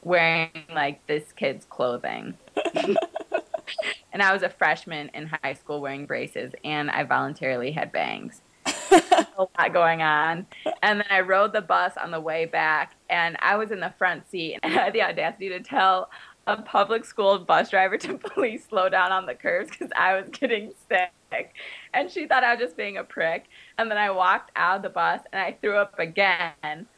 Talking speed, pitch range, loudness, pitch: 195 wpm, 160-210 Hz, -24 LUFS, 185 Hz